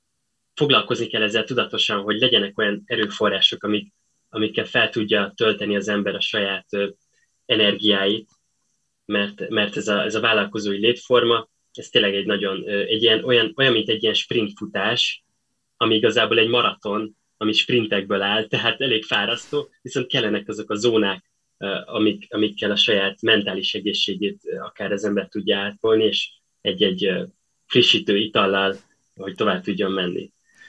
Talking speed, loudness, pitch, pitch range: 145 wpm, -20 LUFS, 105 Hz, 100-110 Hz